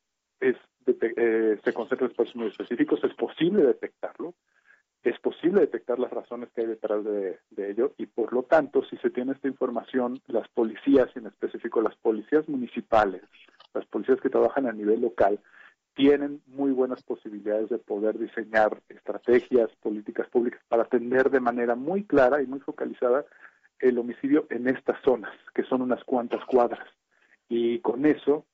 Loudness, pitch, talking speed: -26 LUFS, 130 Hz, 170 wpm